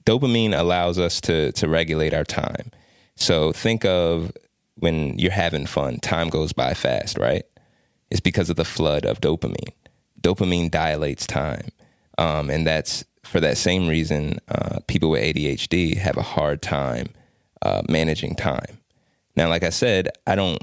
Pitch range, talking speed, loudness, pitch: 75-90 Hz, 155 wpm, -22 LUFS, 85 Hz